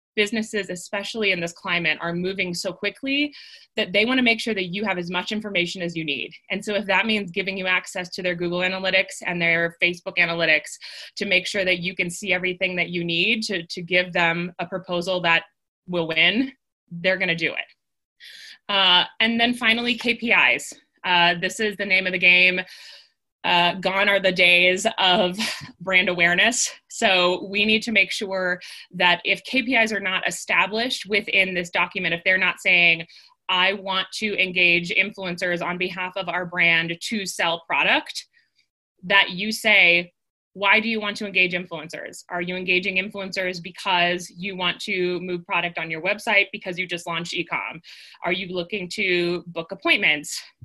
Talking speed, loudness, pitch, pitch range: 180 wpm, -21 LUFS, 185 Hz, 175-200 Hz